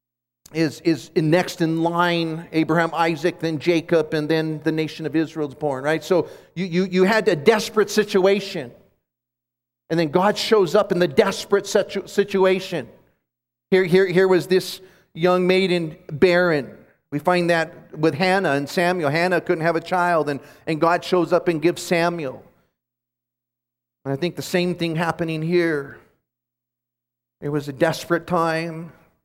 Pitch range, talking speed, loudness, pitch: 150-180 Hz, 160 wpm, -21 LUFS, 165 Hz